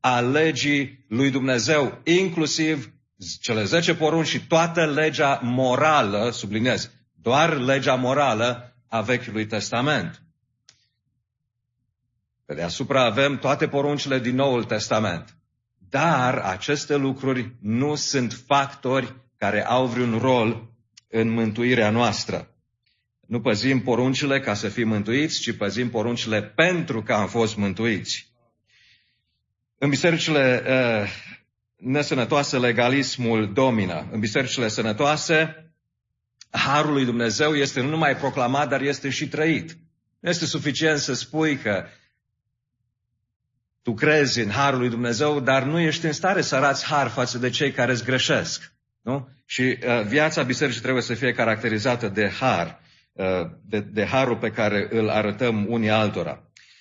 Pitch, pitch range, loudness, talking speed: 125 Hz, 115-140 Hz, -22 LUFS, 130 wpm